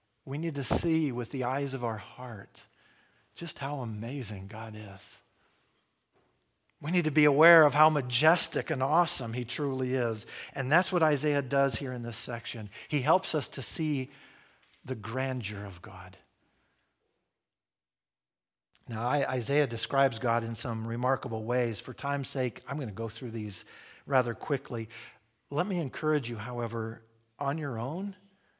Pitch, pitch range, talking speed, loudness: 130 Hz, 115-145 Hz, 155 wpm, -30 LUFS